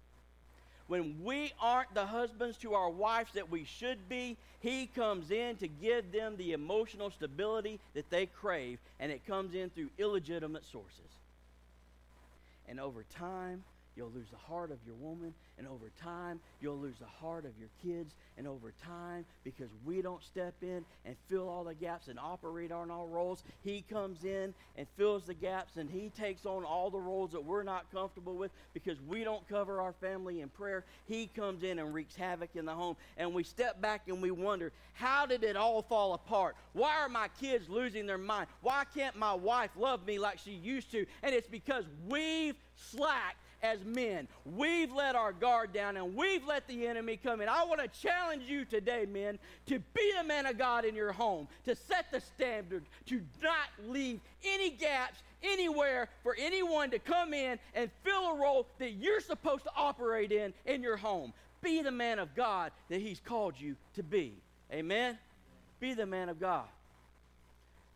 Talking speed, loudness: 190 wpm, -37 LUFS